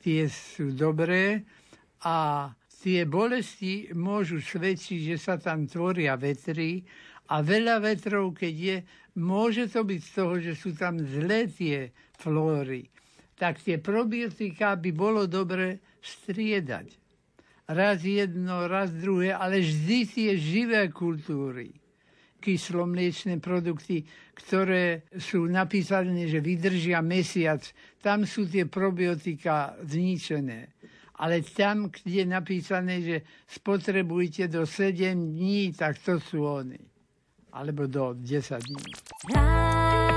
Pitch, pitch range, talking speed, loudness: 180 Hz, 155-195 Hz, 115 wpm, -28 LUFS